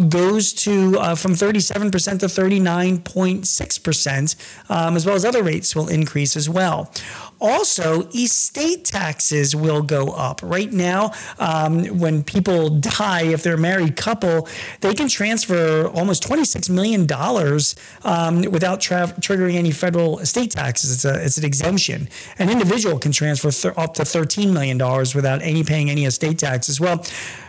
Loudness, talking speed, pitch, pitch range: -18 LUFS, 160 wpm, 170 Hz, 150-190 Hz